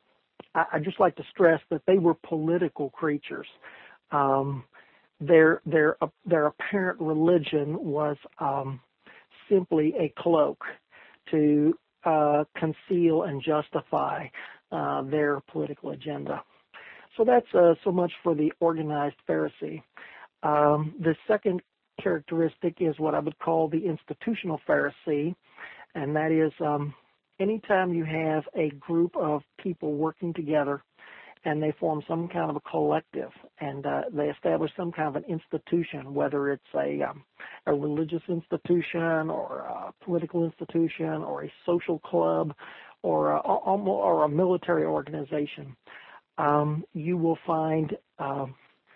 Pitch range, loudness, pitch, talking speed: 150-170 Hz, -27 LUFS, 160 Hz, 130 wpm